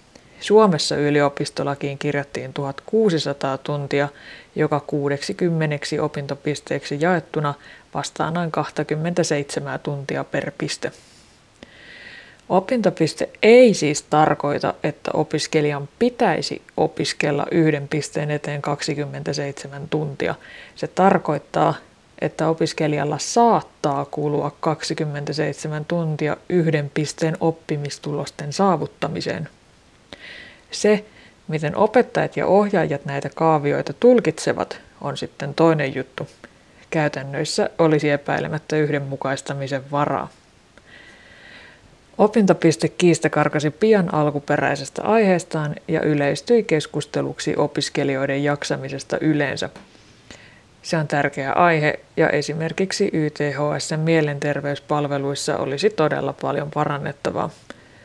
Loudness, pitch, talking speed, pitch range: -21 LUFS, 150 Hz, 85 wpm, 145-160 Hz